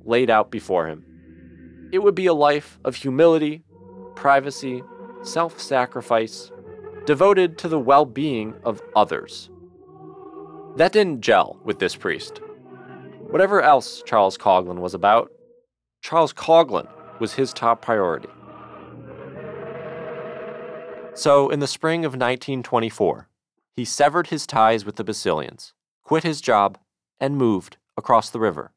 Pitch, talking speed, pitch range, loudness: 140 Hz, 125 wpm, 115-165 Hz, -20 LUFS